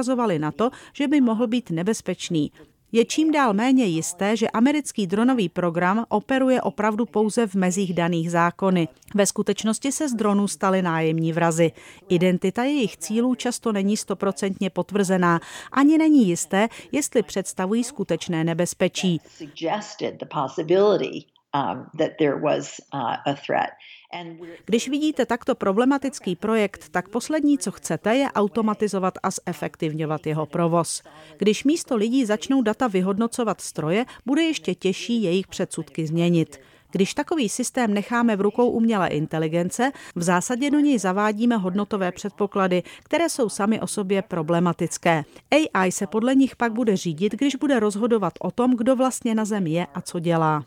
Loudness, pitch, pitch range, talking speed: -23 LUFS, 205 Hz, 175-240 Hz, 135 wpm